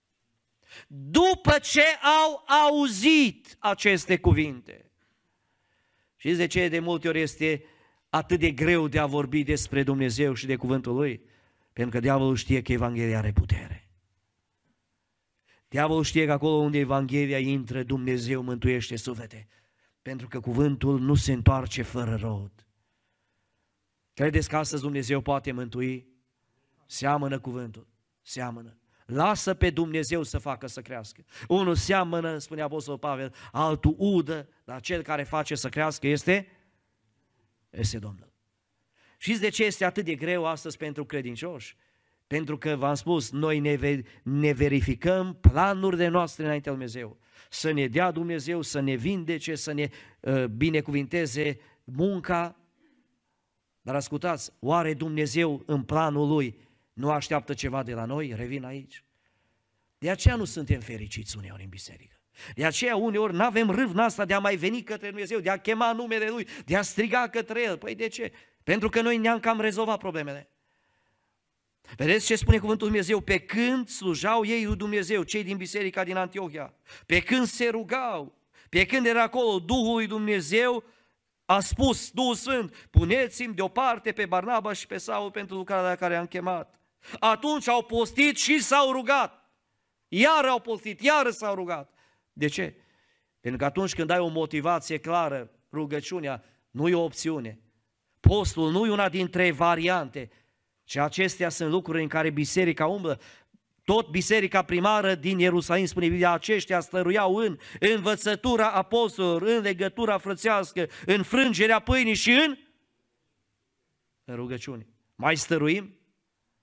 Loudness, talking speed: -26 LUFS, 145 wpm